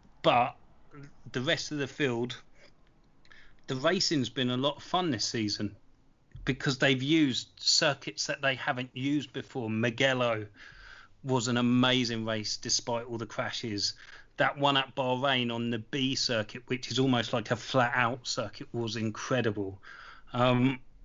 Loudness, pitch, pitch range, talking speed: -29 LUFS, 125 Hz, 115-135 Hz, 150 wpm